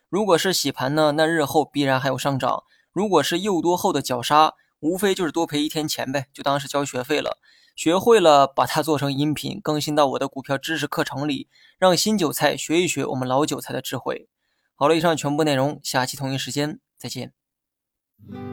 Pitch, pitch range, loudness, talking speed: 150 Hz, 140-165 Hz, -21 LUFS, 300 characters per minute